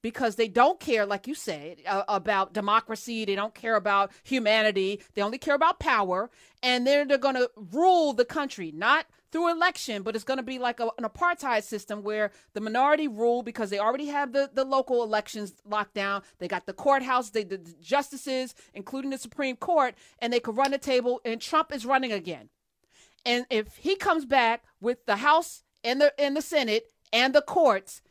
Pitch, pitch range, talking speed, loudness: 240 Hz, 210-280 Hz, 195 wpm, -26 LUFS